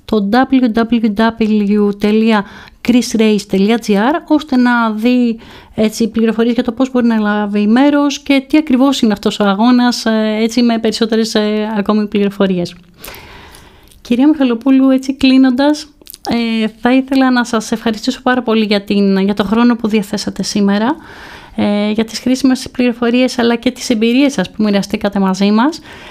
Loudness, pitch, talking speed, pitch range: -13 LUFS, 230 Hz, 135 wpm, 215-255 Hz